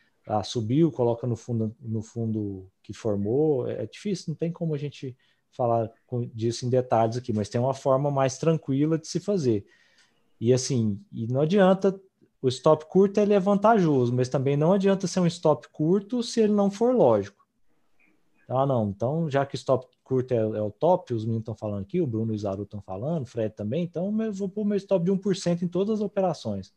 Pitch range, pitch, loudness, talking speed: 115-180 Hz, 135 Hz, -26 LUFS, 205 wpm